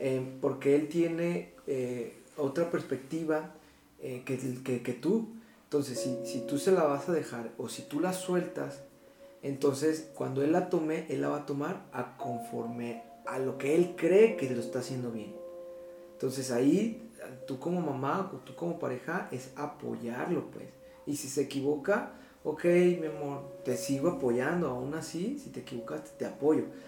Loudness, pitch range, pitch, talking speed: -32 LUFS, 130-175 Hz, 150 Hz, 170 wpm